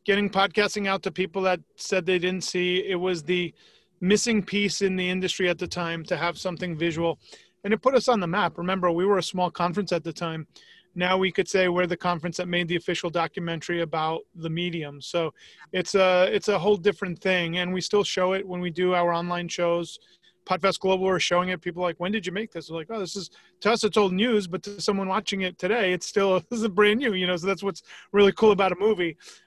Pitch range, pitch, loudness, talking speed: 175-195 Hz, 185 Hz, -25 LUFS, 245 wpm